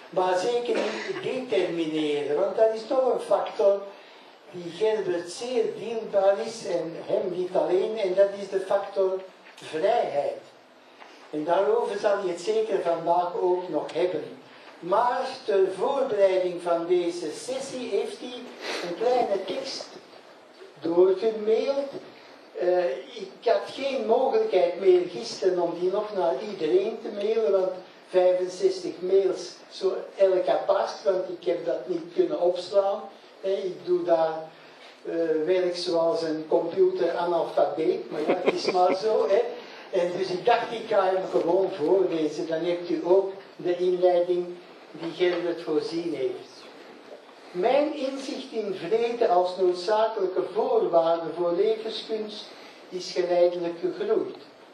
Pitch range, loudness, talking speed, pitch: 175-230 Hz, -26 LUFS, 130 wpm, 190 Hz